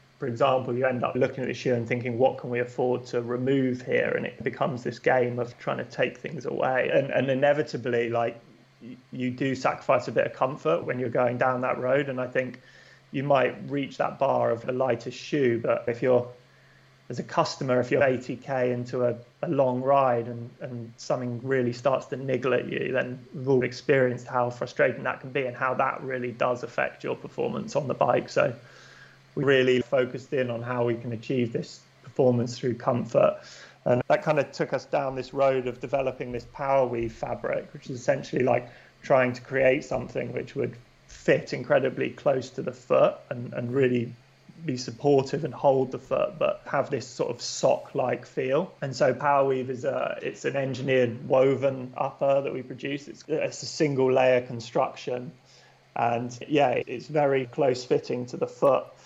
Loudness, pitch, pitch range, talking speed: -27 LUFS, 130 Hz, 120-135 Hz, 195 wpm